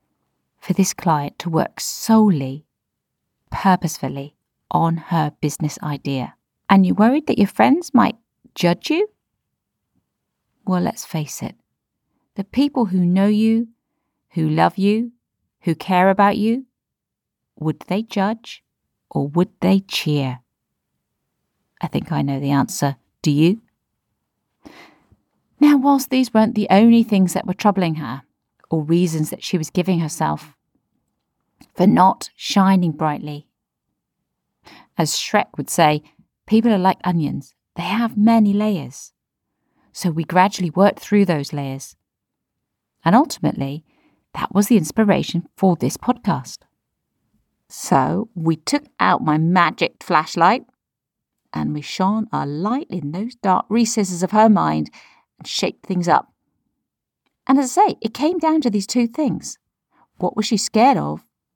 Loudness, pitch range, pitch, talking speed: -19 LUFS, 155-220 Hz, 185 Hz, 135 wpm